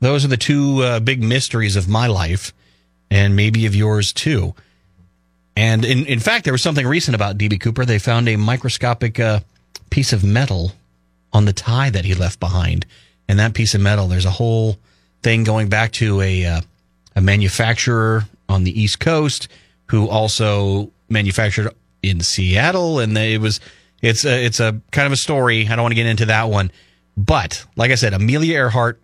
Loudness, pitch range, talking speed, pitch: -17 LUFS, 95-120 Hz, 190 wpm, 110 Hz